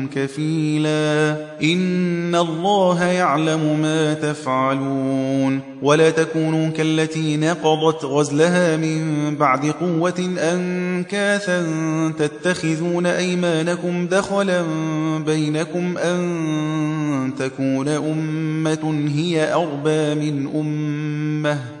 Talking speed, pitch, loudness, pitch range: 70 wpm, 155 Hz, -20 LUFS, 150-170 Hz